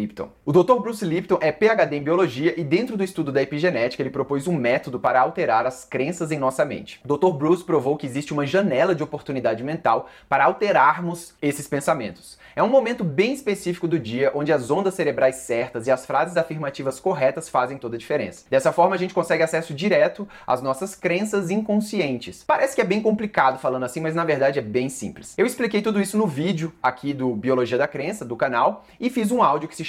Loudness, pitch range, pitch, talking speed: -22 LUFS, 135-190 Hz, 160 Hz, 210 wpm